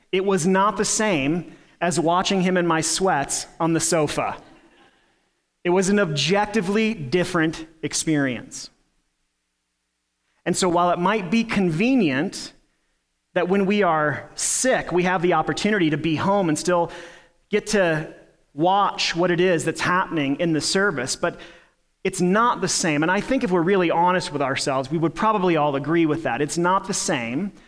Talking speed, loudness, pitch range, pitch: 165 wpm, -21 LUFS, 155-195 Hz, 175 Hz